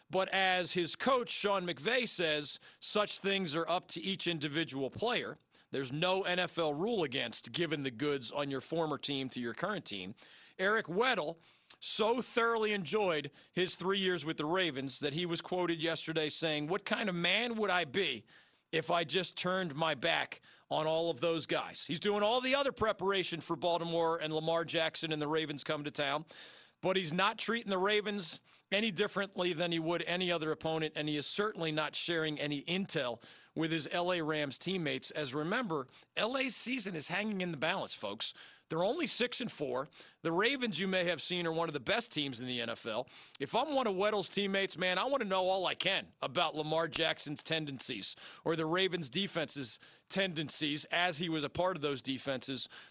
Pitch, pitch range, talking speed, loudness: 170 Hz, 155-190 Hz, 195 wpm, -33 LUFS